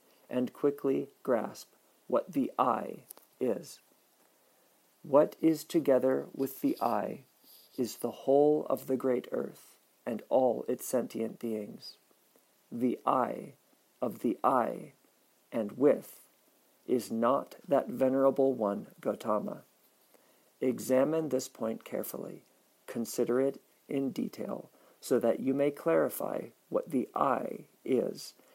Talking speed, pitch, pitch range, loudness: 115 wpm, 135 Hz, 125-140 Hz, -32 LUFS